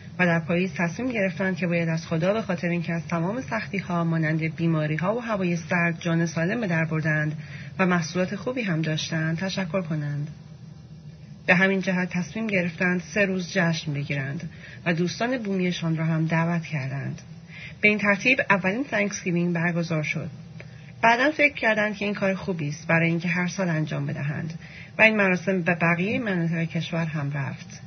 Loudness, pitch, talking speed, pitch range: -24 LUFS, 170 Hz, 170 wpm, 160-190 Hz